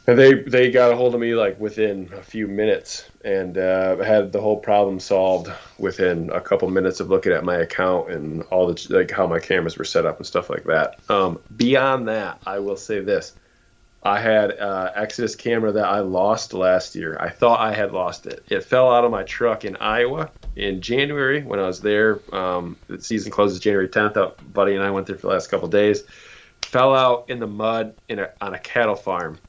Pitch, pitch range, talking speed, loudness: 105 Hz, 95-120 Hz, 220 wpm, -20 LUFS